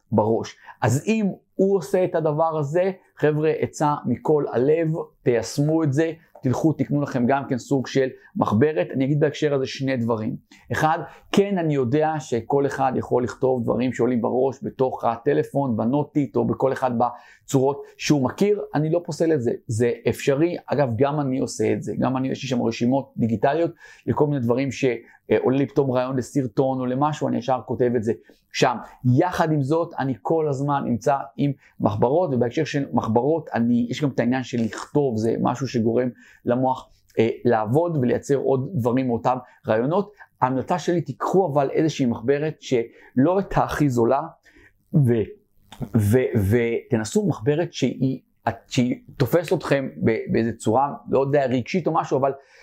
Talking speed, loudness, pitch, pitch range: 160 wpm, -23 LUFS, 135 Hz, 125-155 Hz